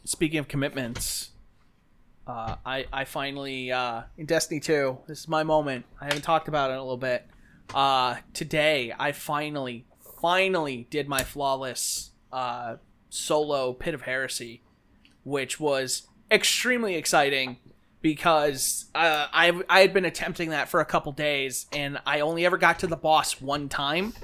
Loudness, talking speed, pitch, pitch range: -26 LUFS, 155 wpm, 145 Hz, 130-160 Hz